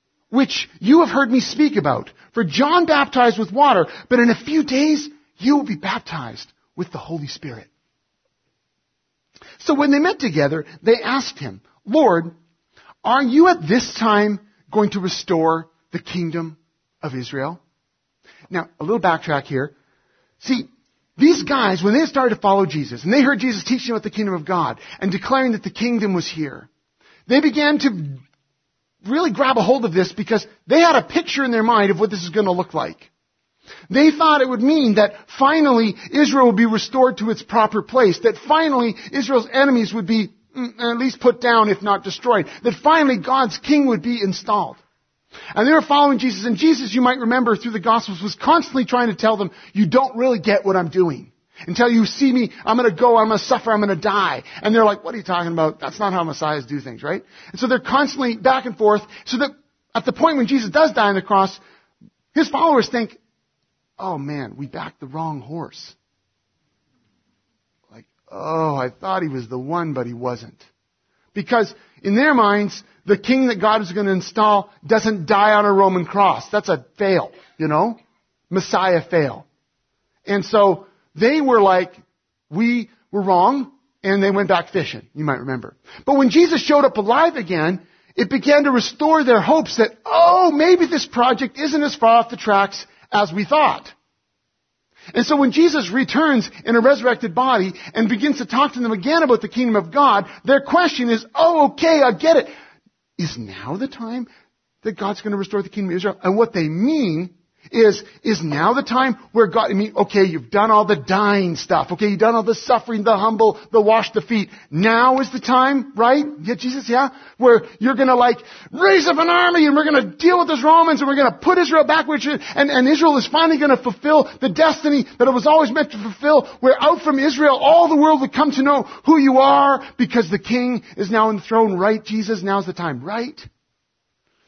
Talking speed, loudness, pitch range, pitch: 200 wpm, -17 LUFS, 195-270 Hz, 225 Hz